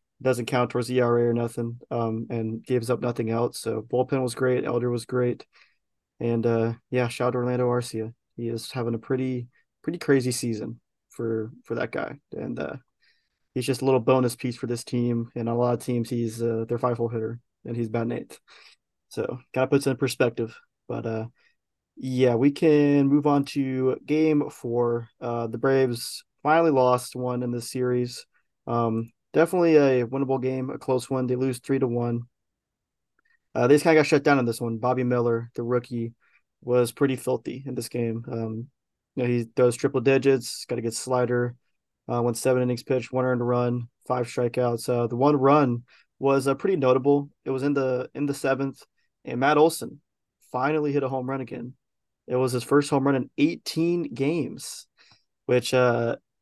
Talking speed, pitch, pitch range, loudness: 195 wpm, 125 Hz, 120-135 Hz, -25 LUFS